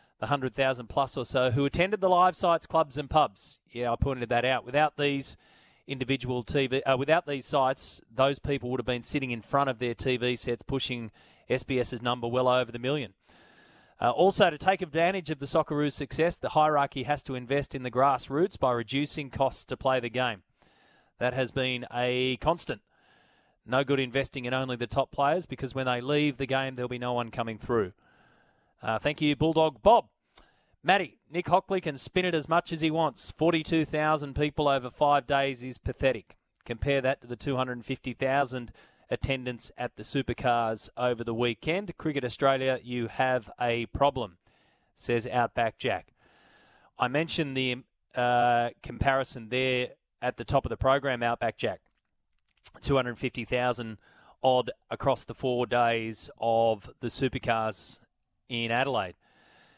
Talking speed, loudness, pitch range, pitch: 165 wpm, -28 LUFS, 120-145 Hz, 130 Hz